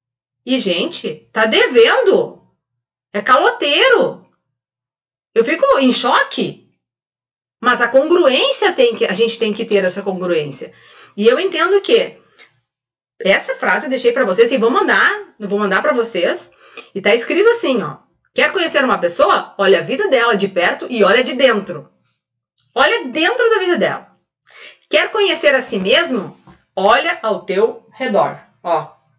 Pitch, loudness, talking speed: 260 Hz, -14 LUFS, 150 wpm